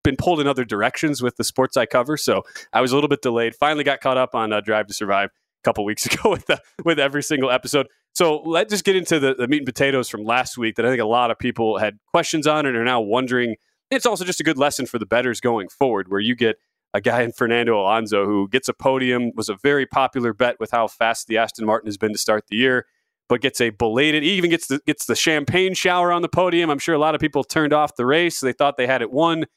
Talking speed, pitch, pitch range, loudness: 270 wpm, 130 Hz, 115-150 Hz, -20 LUFS